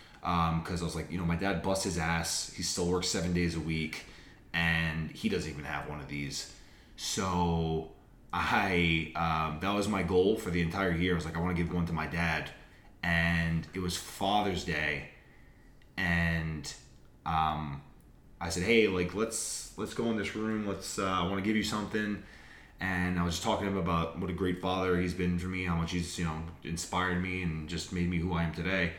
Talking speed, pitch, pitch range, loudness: 215 wpm, 85 Hz, 80-95 Hz, -32 LUFS